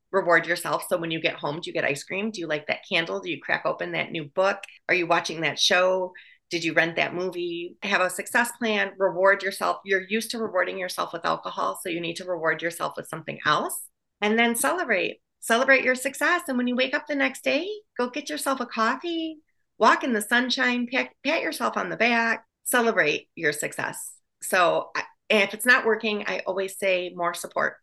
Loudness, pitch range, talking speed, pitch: -24 LUFS, 180-255 Hz, 210 wpm, 210 Hz